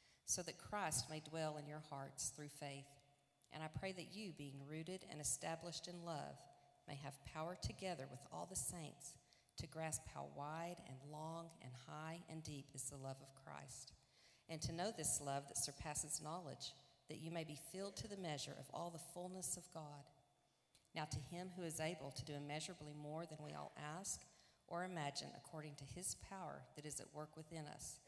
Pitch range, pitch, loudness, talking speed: 140-165 Hz, 150 Hz, -49 LUFS, 195 wpm